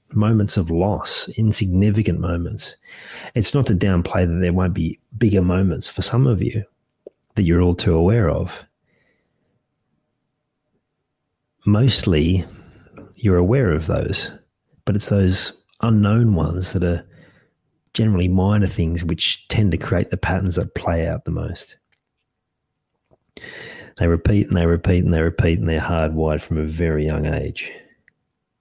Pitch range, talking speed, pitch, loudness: 85-105 Hz, 140 wpm, 90 Hz, -19 LUFS